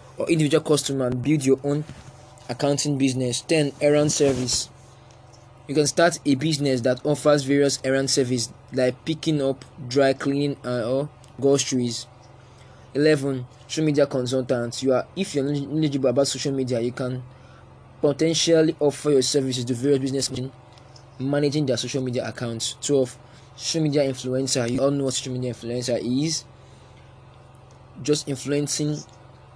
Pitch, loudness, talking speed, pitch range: 130 Hz, -23 LUFS, 150 wpm, 125-145 Hz